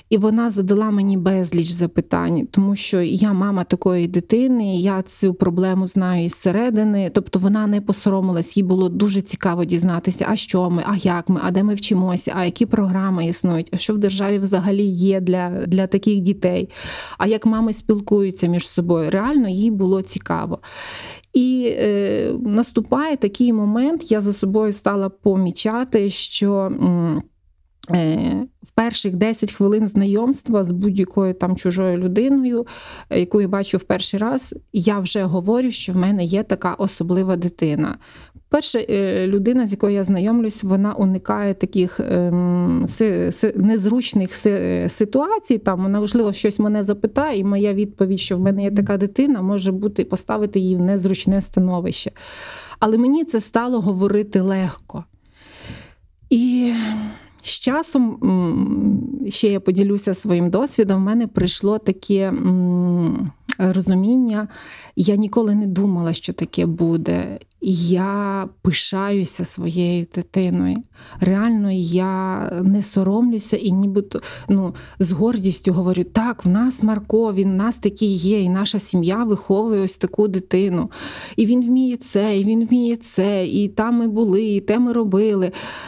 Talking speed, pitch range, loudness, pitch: 145 wpm, 185-215 Hz, -19 LUFS, 200 Hz